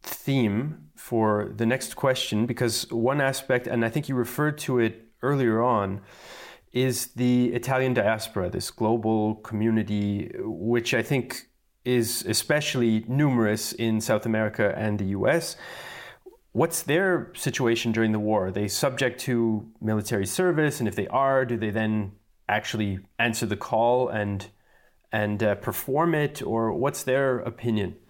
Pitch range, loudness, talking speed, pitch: 110-130 Hz, -25 LUFS, 145 wpm, 115 Hz